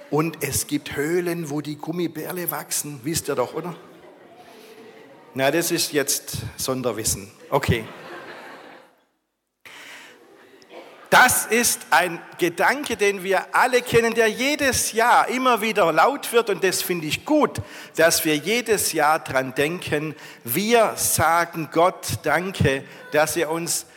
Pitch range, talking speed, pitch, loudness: 150-220 Hz, 130 wpm, 170 Hz, -21 LUFS